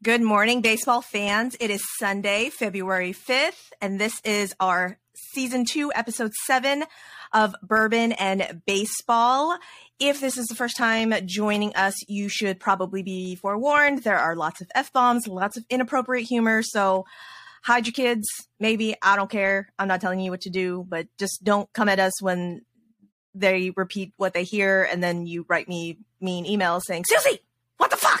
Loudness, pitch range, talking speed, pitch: -23 LUFS, 190-235 Hz, 175 wpm, 205 Hz